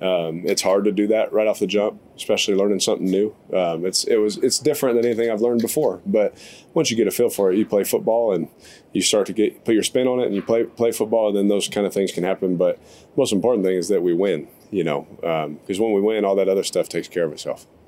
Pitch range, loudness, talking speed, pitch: 95-125 Hz, -20 LUFS, 280 wpm, 110 Hz